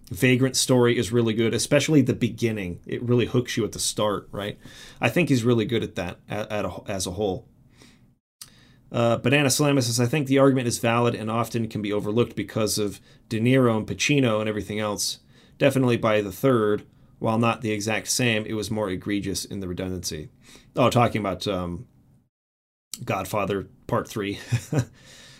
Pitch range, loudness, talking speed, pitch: 105-125 Hz, -24 LUFS, 175 wpm, 115 Hz